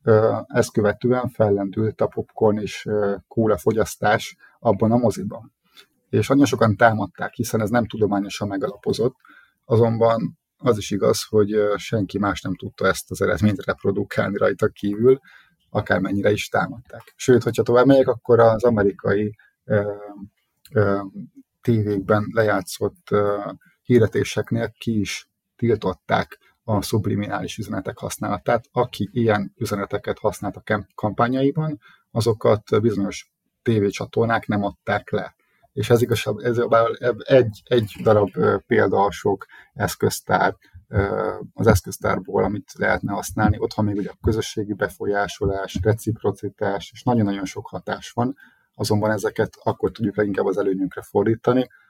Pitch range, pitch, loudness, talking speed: 100-120 Hz, 105 Hz, -21 LUFS, 125 wpm